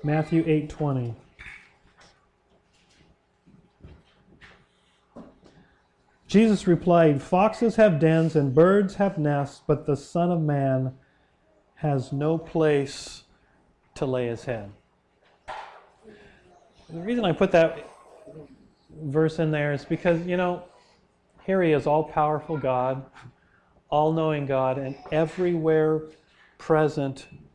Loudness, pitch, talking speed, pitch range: -24 LUFS, 155 Hz, 100 wpm, 140-170 Hz